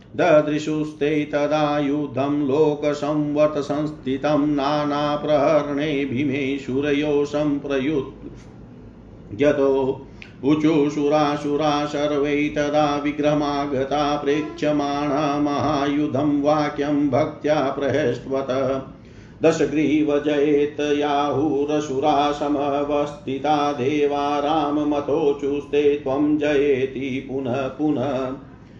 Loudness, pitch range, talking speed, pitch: -21 LUFS, 140-150 Hz, 45 wpm, 145 Hz